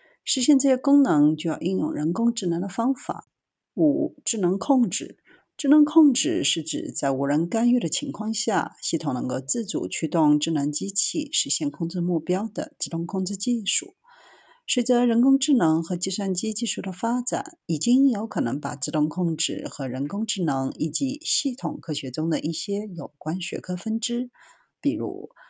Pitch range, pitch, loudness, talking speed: 165-255 Hz, 200 Hz, -24 LUFS, 260 characters per minute